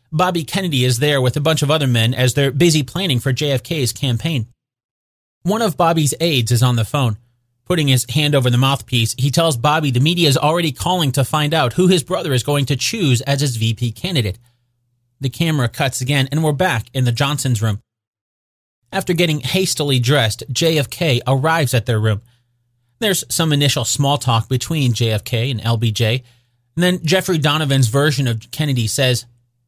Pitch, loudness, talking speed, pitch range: 135 Hz, -17 LUFS, 180 wpm, 120-155 Hz